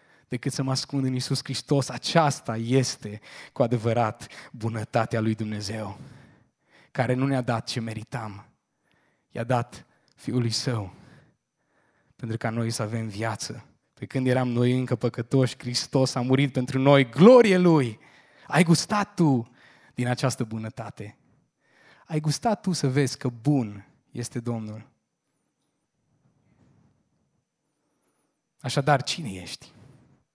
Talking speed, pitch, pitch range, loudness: 120 wpm, 125 Hz, 115-135 Hz, -25 LUFS